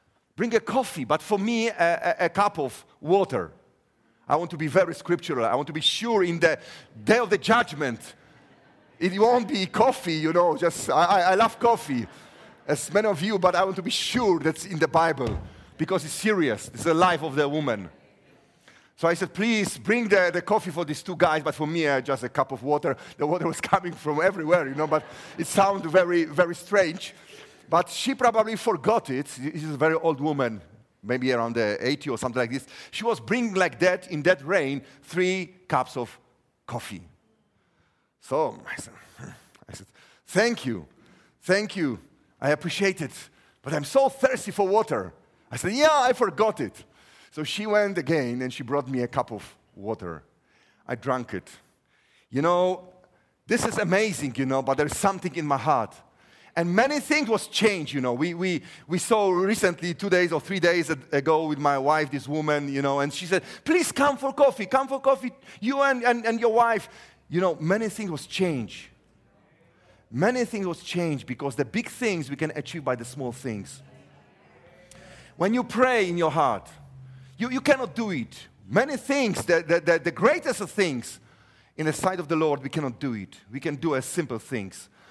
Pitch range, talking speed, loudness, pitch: 145-205 Hz, 195 wpm, -25 LUFS, 175 Hz